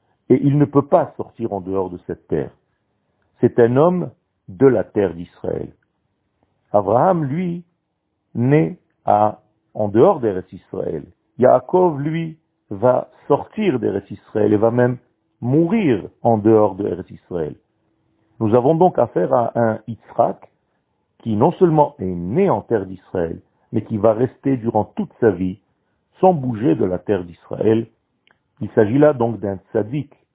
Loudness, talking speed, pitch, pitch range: -18 LUFS, 150 wpm, 115 Hz, 105-145 Hz